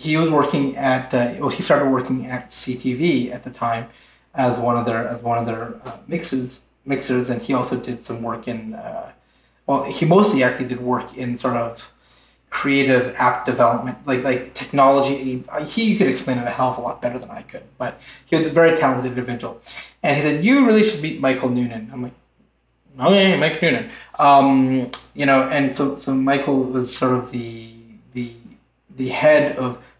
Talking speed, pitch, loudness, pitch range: 195 wpm, 130 Hz, -19 LUFS, 125-140 Hz